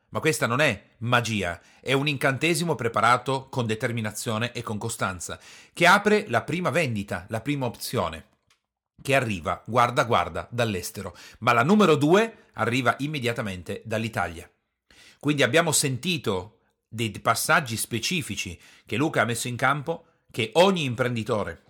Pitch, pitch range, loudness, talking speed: 120 Hz, 105-145 Hz, -24 LUFS, 135 wpm